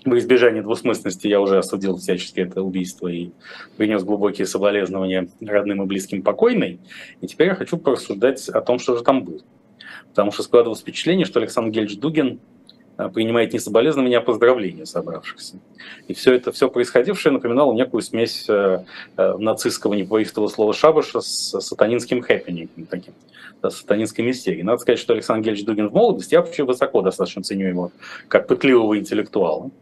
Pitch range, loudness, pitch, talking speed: 95-115 Hz, -19 LUFS, 105 Hz, 160 wpm